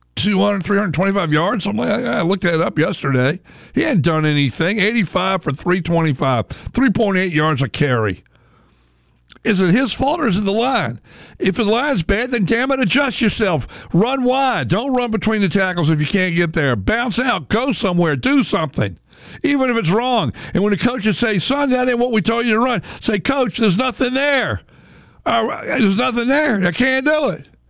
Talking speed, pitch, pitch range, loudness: 185 wpm, 205 Hz, 170-245 Hz, -17 LUFS